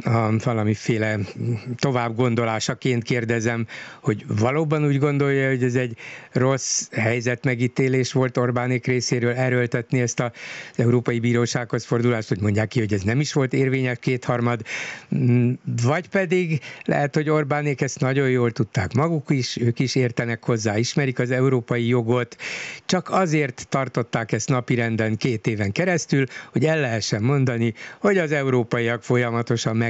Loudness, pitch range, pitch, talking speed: -22 LUFS, 120-140 Hz, 125 Hz, 140 wpm